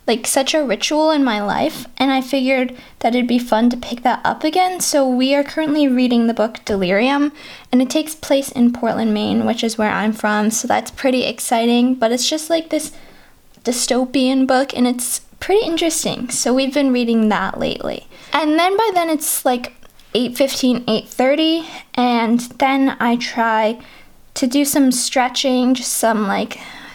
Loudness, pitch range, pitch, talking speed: -17 LUFS, 235-285 Hz, 255 Hz, 175 wpm